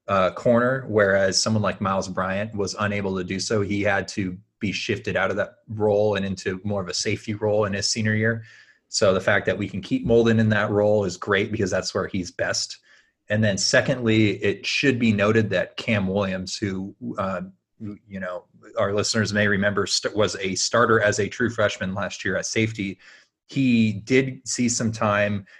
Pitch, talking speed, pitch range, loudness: 105 Hz, 200 wpm, 100-110 Hz, -23 LUFS